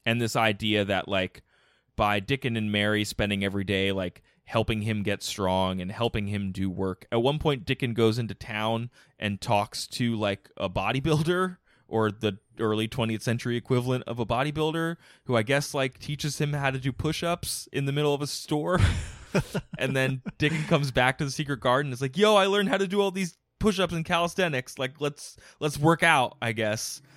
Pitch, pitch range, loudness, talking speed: 125 Hz, 110-150 Hz, -27 LUFS, 195 wpm